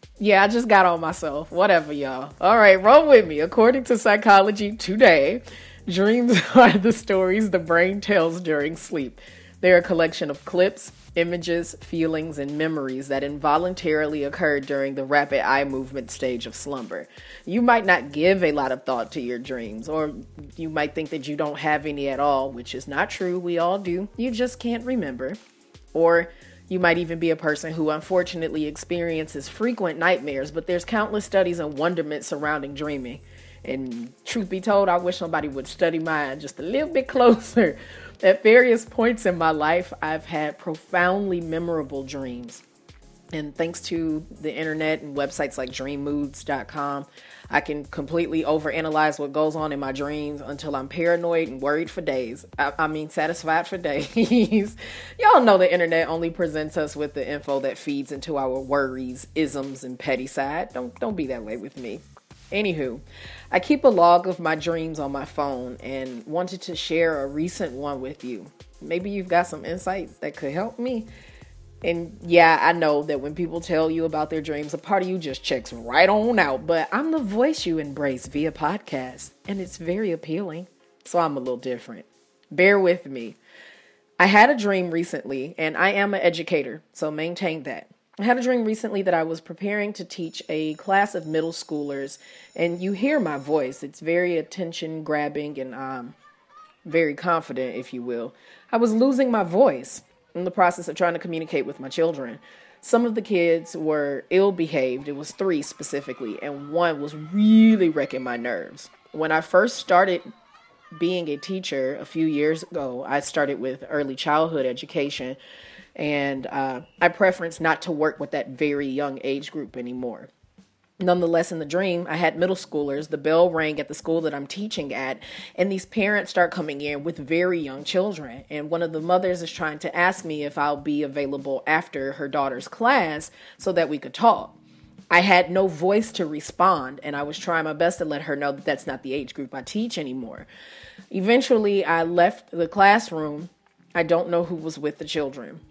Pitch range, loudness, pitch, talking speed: 145-180 Hz, -23 LUFS, 160 Hz, 185 wpm